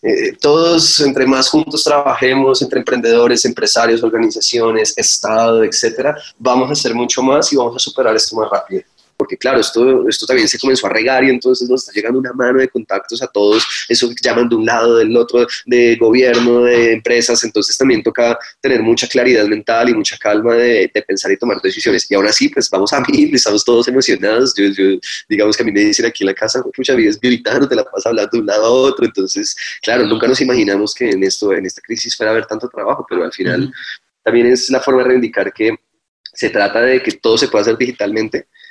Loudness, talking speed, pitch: -13 LUFS, 220 wpm, 130 Hz